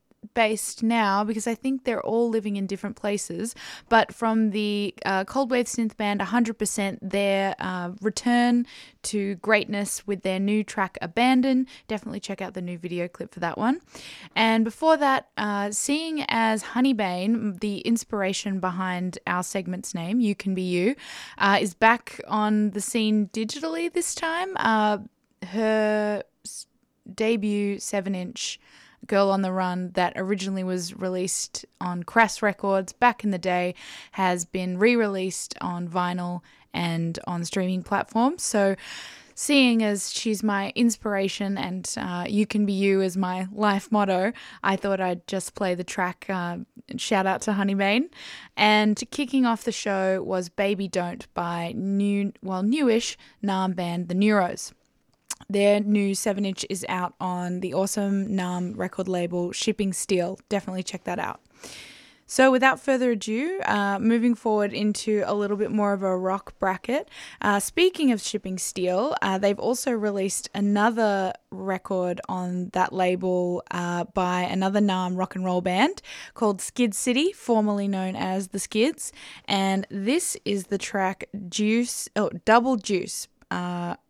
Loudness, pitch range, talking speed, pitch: -25 LUFS, 185-225 Hz, 155 wpm, 200 Hz